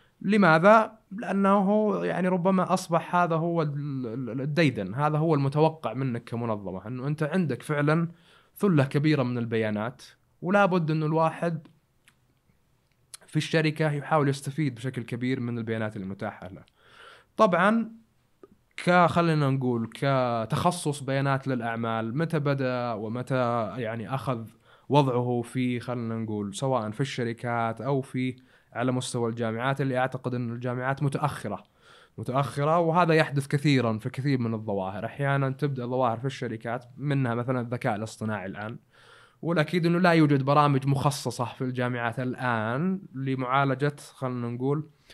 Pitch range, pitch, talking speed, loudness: 120-155 Hz, 135 Hz, 125 wpm, -27 LUFS